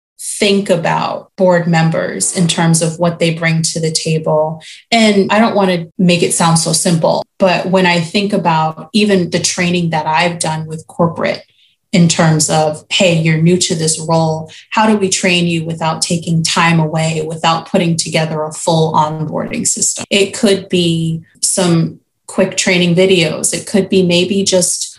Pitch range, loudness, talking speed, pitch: 160-190 Hz, -13 LUFS, 175 wpm, 175 Hz